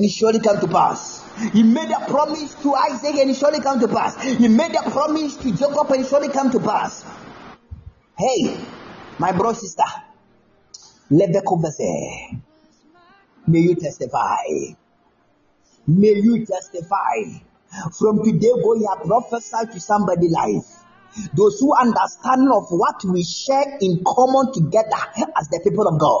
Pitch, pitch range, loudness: 225 Hz, 195-270 Hz, -19 LUFS